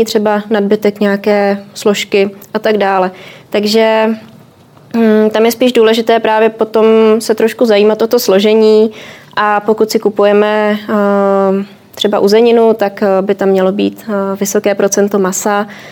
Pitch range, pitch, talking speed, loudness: 200-220 Hz, 210 Hz, 130 wpm, -11 LUFS